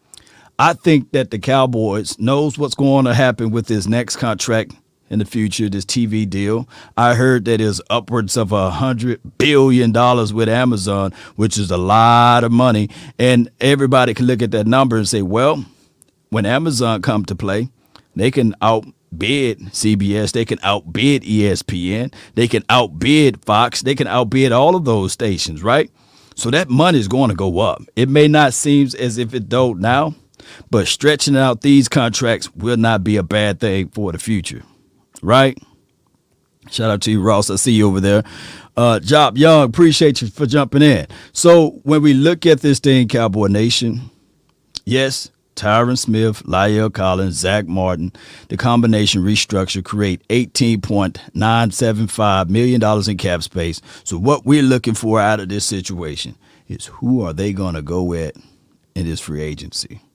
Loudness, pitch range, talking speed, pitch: -15 LUFS, 100-130 Hz, 170 wpm, 115 Hz